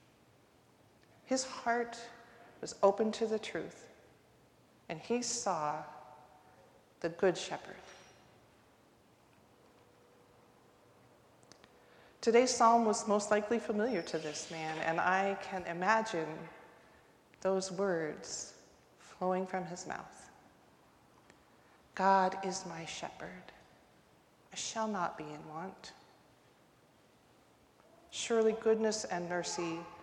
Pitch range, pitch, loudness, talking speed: 165-220 Hz, 190 Hz, -34 LUFS, 90 wpm